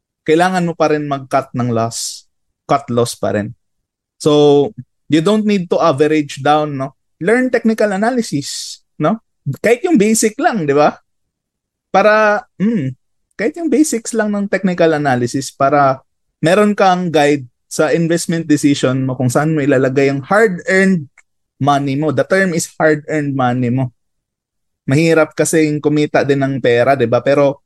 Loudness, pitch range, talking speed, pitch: -14 LUFS, 135-185 Hz, 150 wpm, 150 Hz